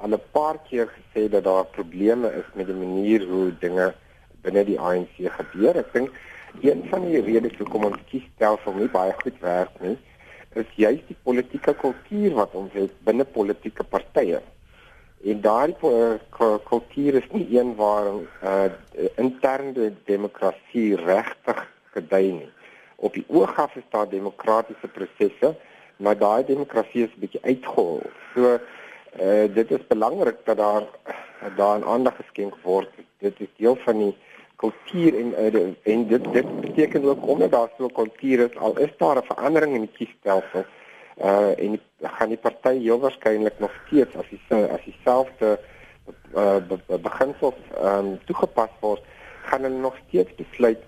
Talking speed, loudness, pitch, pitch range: 160 wpm, -23 LUFS, 110 Hz, 100-125 Hz